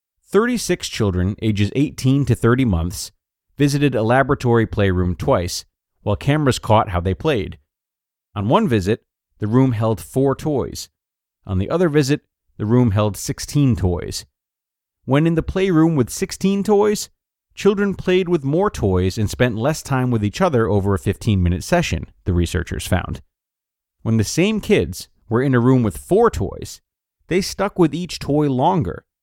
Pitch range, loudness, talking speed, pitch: 100-155 Hz, -19 LUFS, 160 wpm, 120 Hz